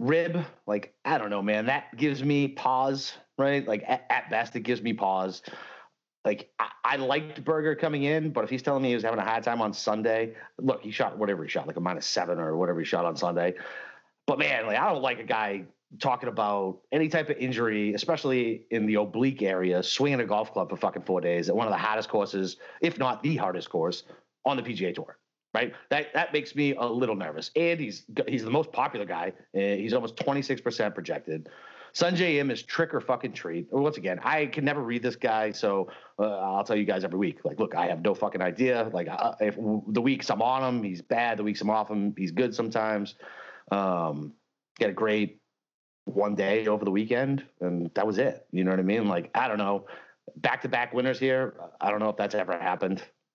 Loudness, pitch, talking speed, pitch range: -28 LUFS, 115 Hz, 230 wpm, 100-135 Hz